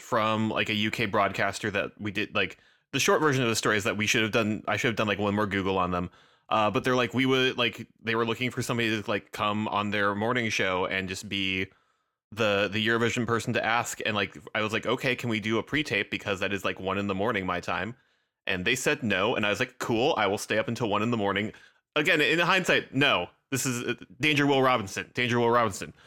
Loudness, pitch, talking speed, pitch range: -27 LUFS, 110 Hz, 255 wpm, 100-120 Hz